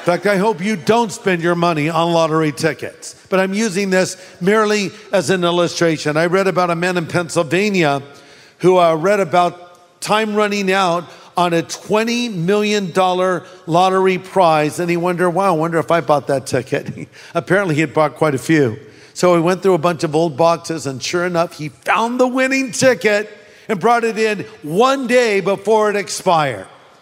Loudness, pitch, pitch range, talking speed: -16 LUFS, 180 Hz, 165-205 Hz, 185 wpm